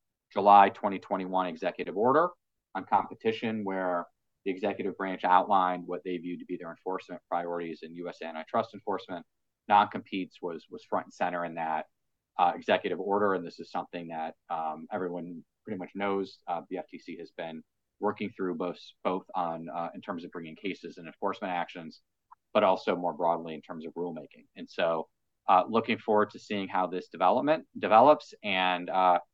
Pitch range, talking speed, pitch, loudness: 85-95 Hz, 170 wpm, 90 Hz, -30 LUFS